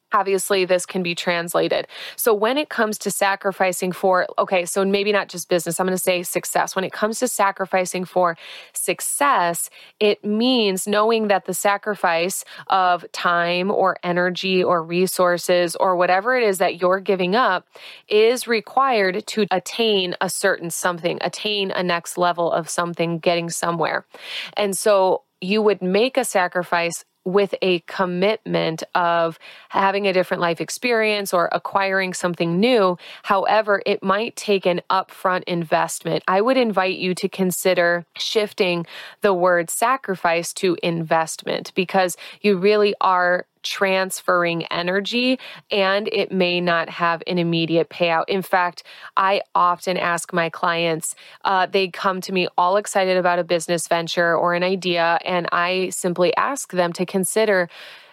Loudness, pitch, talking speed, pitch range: -20 LUFS, 185 Hz, 150 wpm, 175-200 Hz